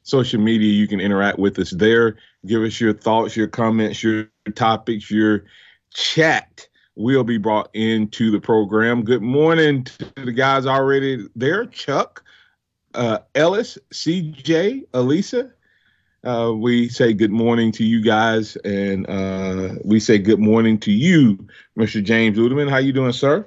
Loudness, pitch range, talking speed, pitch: -18 LUFS, 110-130 Hz, 150 wpm, 115 Hz